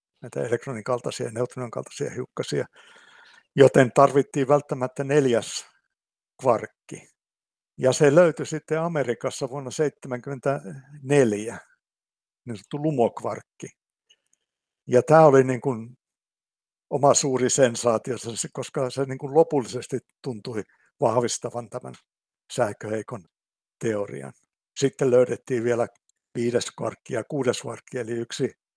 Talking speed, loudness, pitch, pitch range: 105 wpm, -24 LUFS, 130 Hz, 120-140 Hz